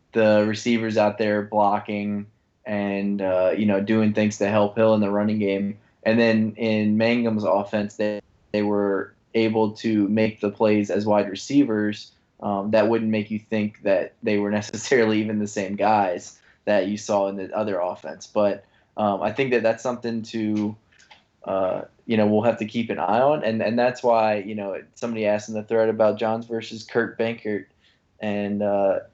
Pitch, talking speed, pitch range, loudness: 105 Hz, 185 wpm, 105-110 Hz, -23 LUFS